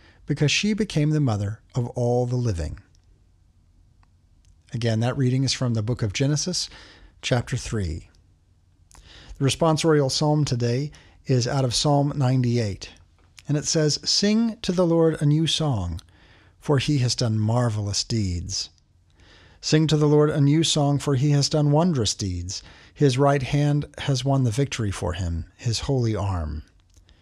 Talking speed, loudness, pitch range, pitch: 155 wpm, -23 LUFS, 90-145 Hz, 120 Hz